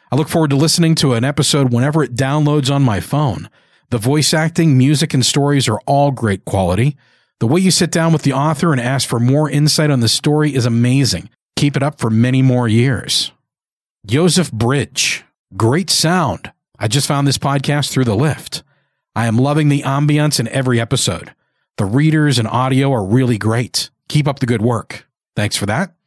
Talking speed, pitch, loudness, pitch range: 195 wpm, 140 Hz, -15 LUFS, 120-150 Hz